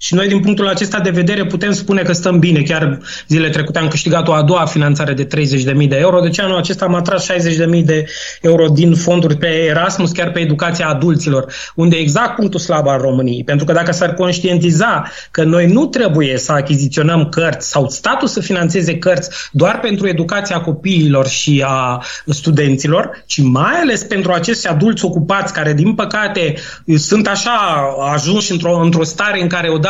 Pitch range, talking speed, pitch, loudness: 150-185 Hz, 185 wpm, 170 Hz, -13 LUFS